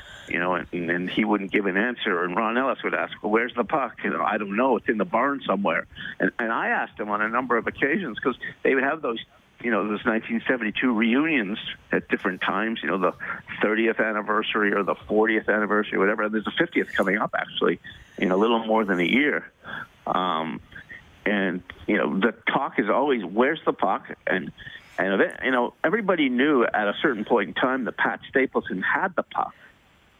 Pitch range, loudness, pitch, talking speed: 95-115 Hz, -24 LUFS, 105 Hz, 210 wpm